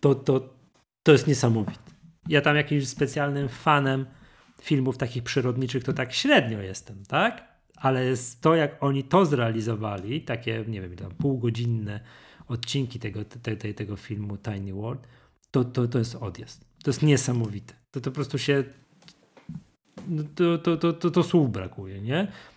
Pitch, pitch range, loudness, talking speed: 130 Hz, 115-145 Hz, -26 LUFS, 155 wpm